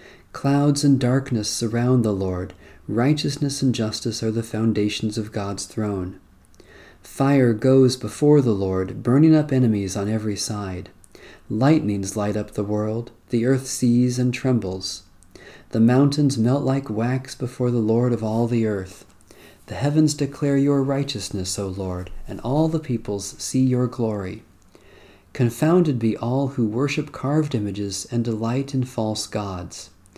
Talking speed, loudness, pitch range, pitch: 145 wpm, -22 LUFS, 105-130 Hz, 115 Hz